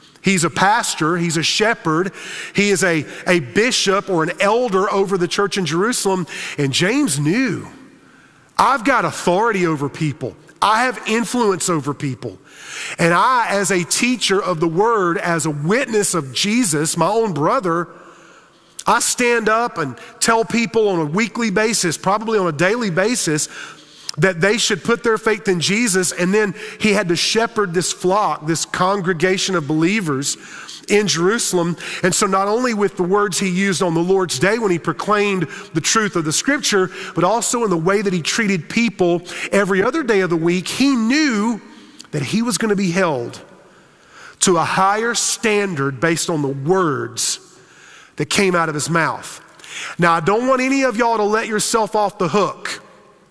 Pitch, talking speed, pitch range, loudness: 190 Hz, 175 wpm, 170-215 Hz, -17 LUFS